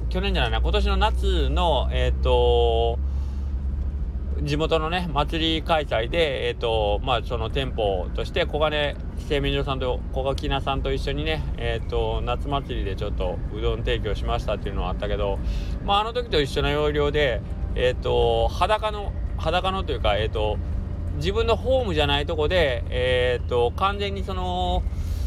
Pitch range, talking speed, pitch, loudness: 80-125 Hz, 330 characters per minute, 100 Hz, -24 LUFS